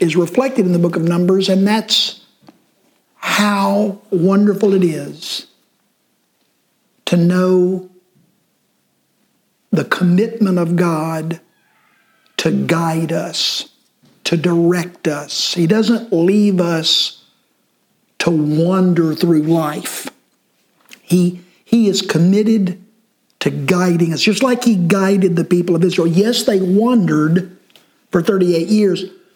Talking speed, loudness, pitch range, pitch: 110 wpm, -15 LUFS, 170-205 Hz, 180 Hz